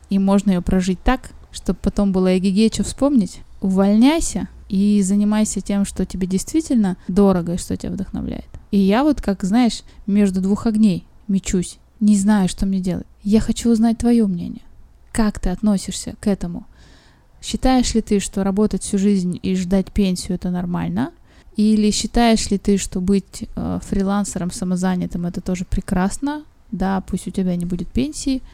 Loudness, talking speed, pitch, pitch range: -19 LUFS, 160 wpm, 200 Hz, 190-220 Hz